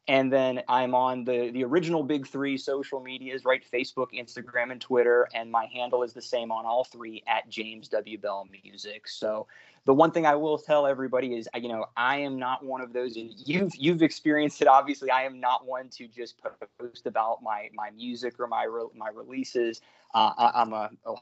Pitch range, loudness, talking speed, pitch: 120-135 Hz, -27 LUFS, 205 wpm, 125 Hz